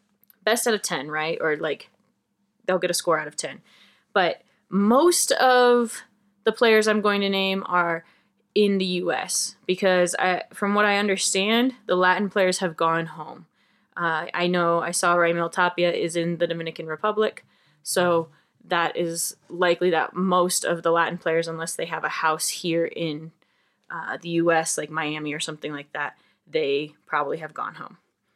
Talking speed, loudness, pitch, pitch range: 175 wpm, -23 LUFS, 180 Hz, 165-205 Hz